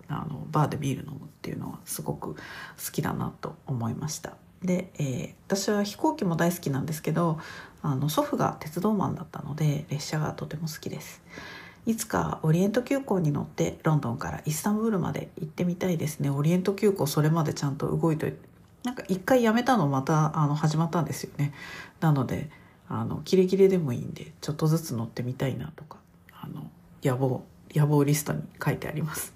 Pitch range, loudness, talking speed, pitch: 145-185 Hz, -28 LUFS, 400 characters per minute, 160 Hz